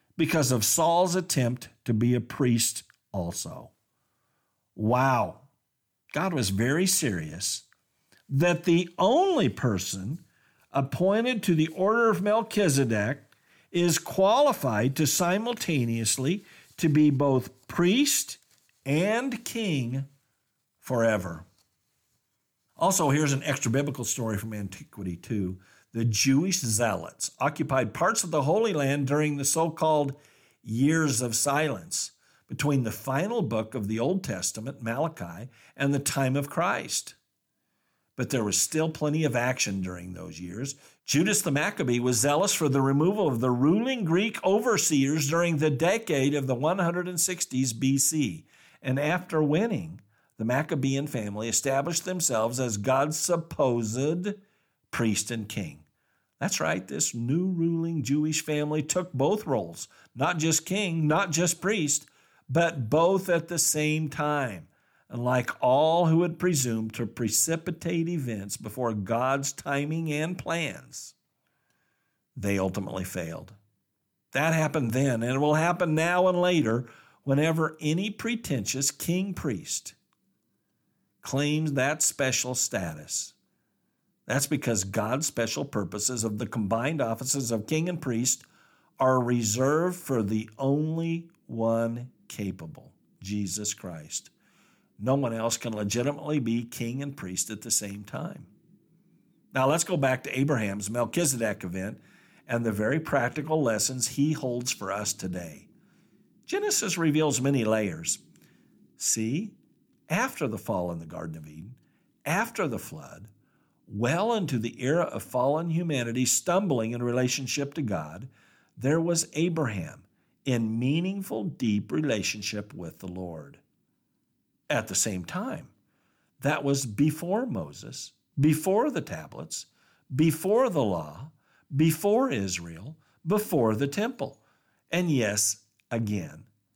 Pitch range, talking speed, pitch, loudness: 115-160 Hz, 125 wpm, 140 Hz, -27 LUFS